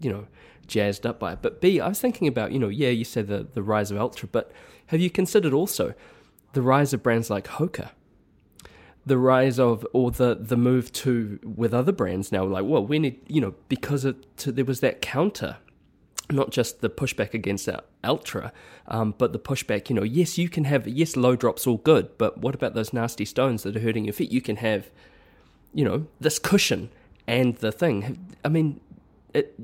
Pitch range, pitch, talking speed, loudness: 110-145 Hz, 125 Hz, 210 wpm, -25 LUFS